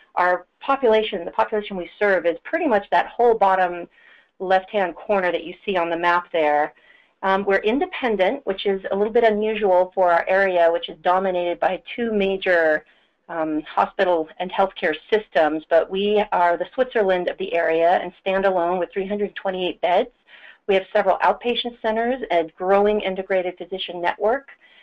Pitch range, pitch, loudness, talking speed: 175-210 Hz, 190 Hz, -21 LUFS, 165 wpm